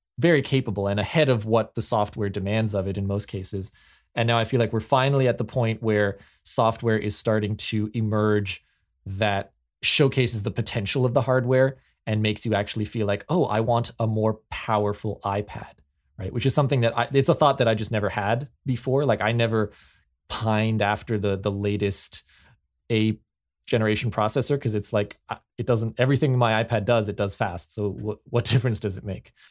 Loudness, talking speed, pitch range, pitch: -24 LUFS, 195 wpm, 100-120 Hz, 110 Hz